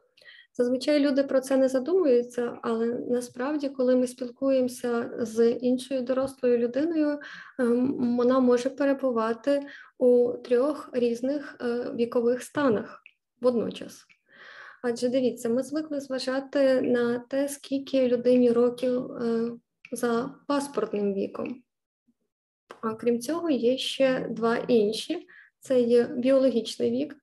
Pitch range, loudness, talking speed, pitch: 240-275 Hz, -26 LUFS, 105 wpm, 250 Hz